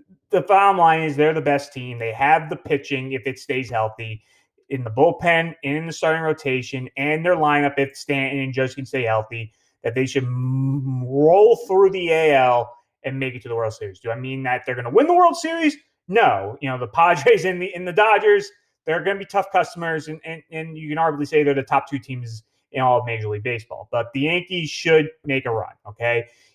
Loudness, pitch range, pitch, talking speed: -20 LUFS, 125-165 Hz, 140 Hz, 230 wpm